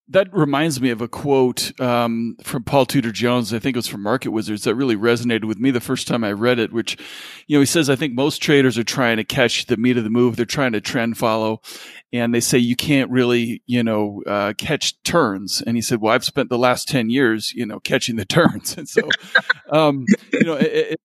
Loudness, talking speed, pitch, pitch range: -19 LUFS, 240 wpm, 120 Hz, 115-135 Hz